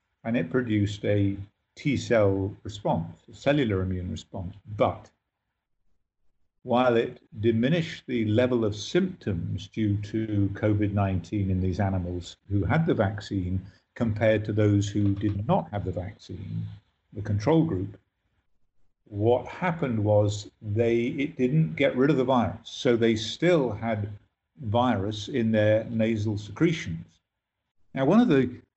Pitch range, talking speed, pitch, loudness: 100-115 Hz, 135 wpm, 105 Hz, -26 LUFS